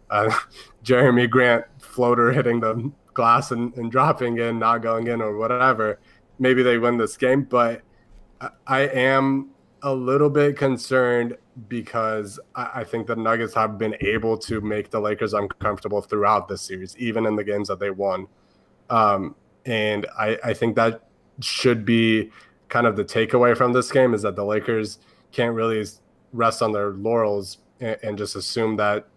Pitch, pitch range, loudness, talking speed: 115 Hz, 110-125 Hz, -21 LUFS, 170 wpm